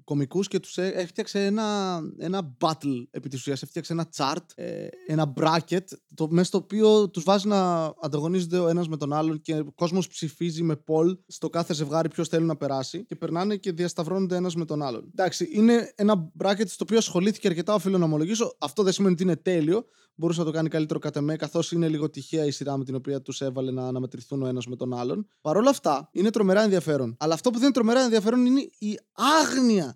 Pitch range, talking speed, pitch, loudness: 155-195 Hz, 215 wpm, 170 Hz, -25 LUFS